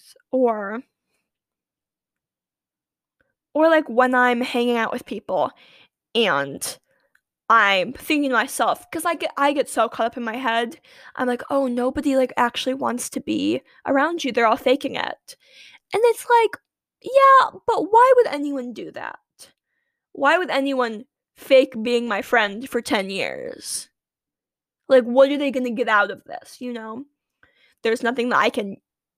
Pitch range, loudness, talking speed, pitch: 240-290 Hz, -20 LUFS, 160 wpm, 260 Hz